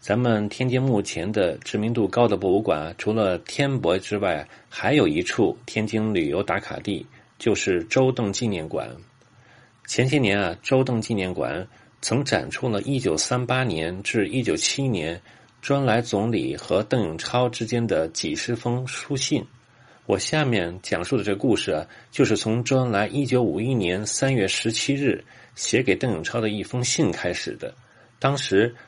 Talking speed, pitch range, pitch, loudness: 250 characters per minute, 105-130 Hz, 120 Hz, -23 LUFS